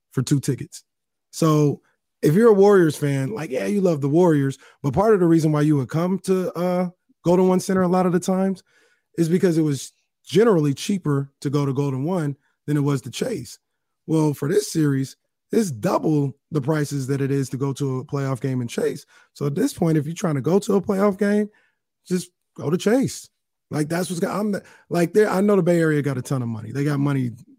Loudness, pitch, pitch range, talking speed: -21 LUFS, 160 Hz, 140-185 Hz, 230 wpm